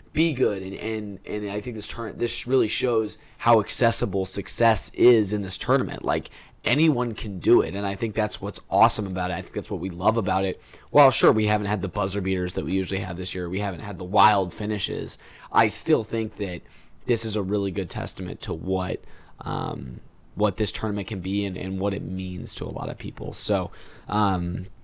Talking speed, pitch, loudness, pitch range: 215 wpm, 100 Hz, -24 LUFS, 95-110 Hz